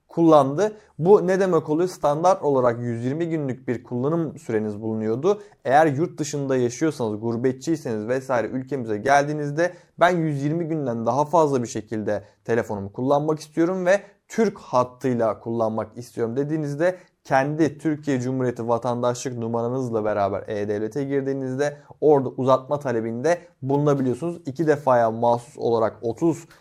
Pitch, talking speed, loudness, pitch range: 135 Hz, 120 wpm, -23 LUFS, 120-160 Hz